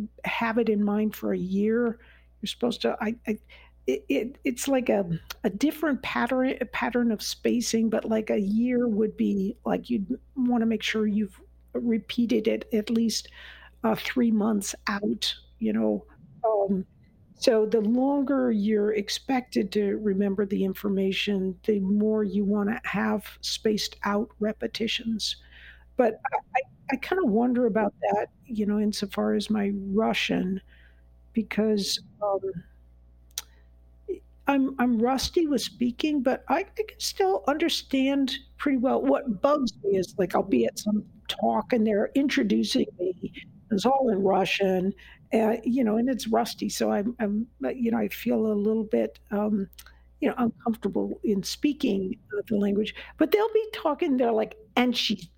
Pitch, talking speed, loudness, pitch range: 220 Hz, 155 wpm, -26 LUFS, 205-245 Hz